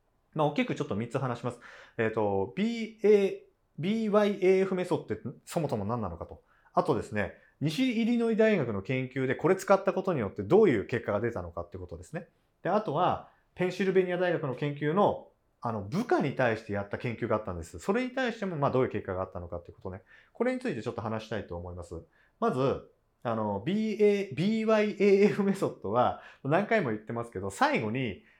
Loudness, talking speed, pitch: -29 LUFS, 405 characters per minute, 135 Hz